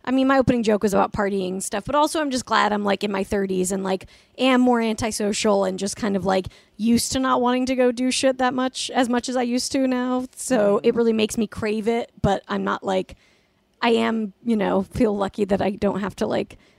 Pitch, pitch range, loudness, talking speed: 225 Hz, 200-255 Hz, -22 LUFS, 250 wpm